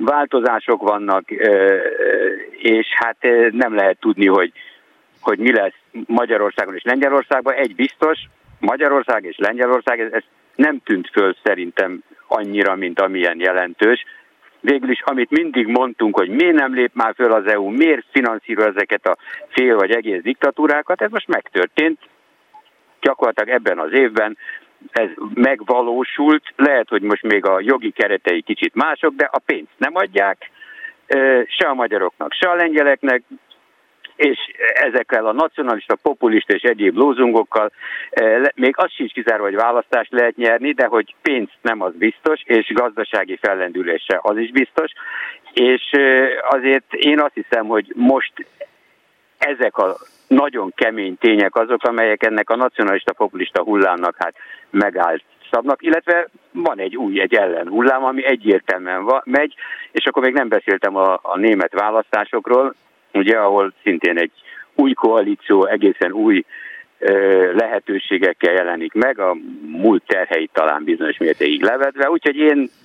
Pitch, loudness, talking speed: 140 Hz, -17 LUFS, 140 wpm